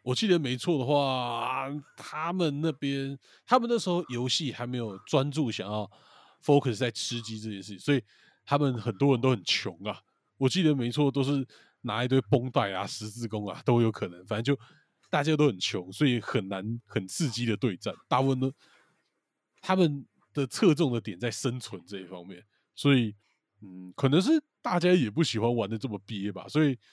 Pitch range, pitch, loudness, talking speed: 110-145 Hz, 125 Hz, -28 LUFS, 280 characters per minute